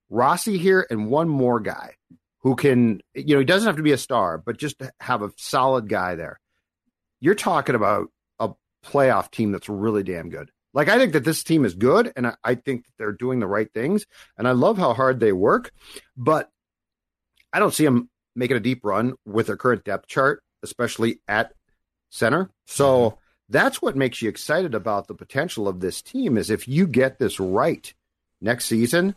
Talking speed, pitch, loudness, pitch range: 200 wpm, 125 Hz, -22 LUFS, 110-145 Hz